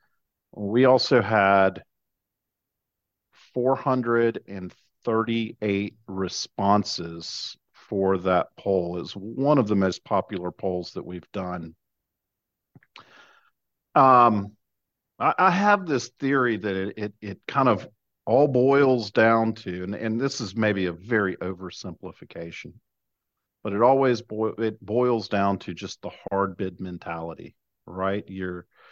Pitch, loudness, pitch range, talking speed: 100 Hz, -24 LUFS, 90-115 Hz, 120 wpm